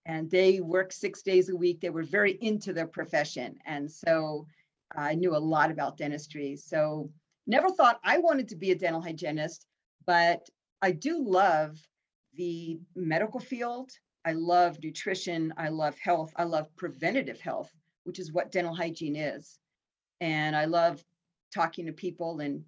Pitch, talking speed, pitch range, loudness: 170 Hz, 160 wpm, 155-185 Hz, -29 LUFS